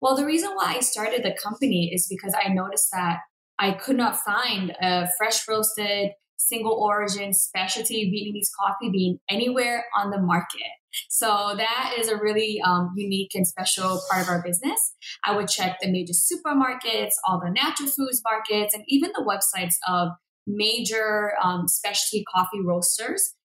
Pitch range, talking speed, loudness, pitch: 185-230 Hz, 165 wpm, -23 LUFS, 205 Hz